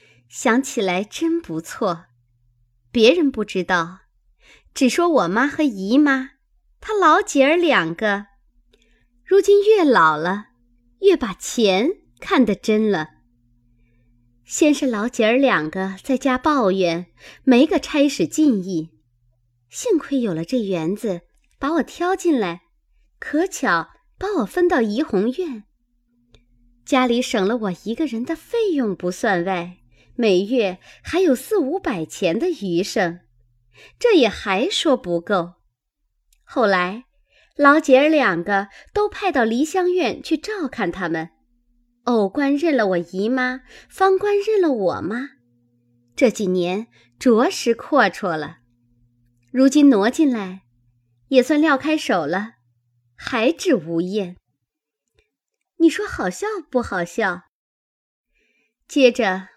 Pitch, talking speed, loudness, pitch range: 230 Hz, 170 characters per minute, -19 LUFS, 175-290 Hz